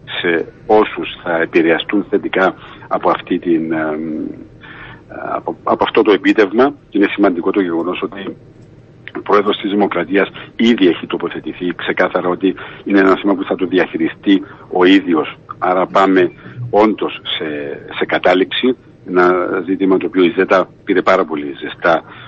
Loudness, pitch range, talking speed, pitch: -15 LUFS, 90-105 Hz, 145 wpm, 95 Hz